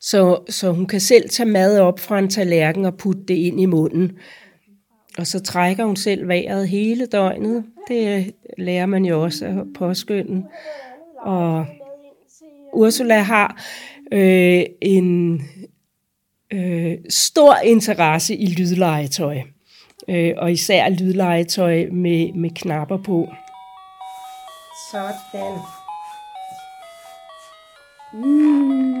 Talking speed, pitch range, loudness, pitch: 110 wpm, 175-220 Hz, -18 LUFS, 190 Hz